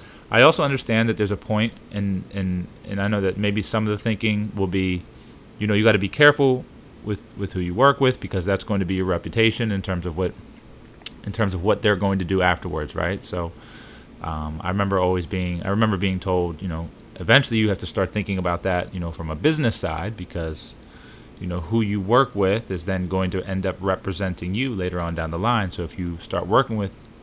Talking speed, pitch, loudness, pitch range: 235 wpm, 95 Hz, -23 LUFS, 90-110 Hz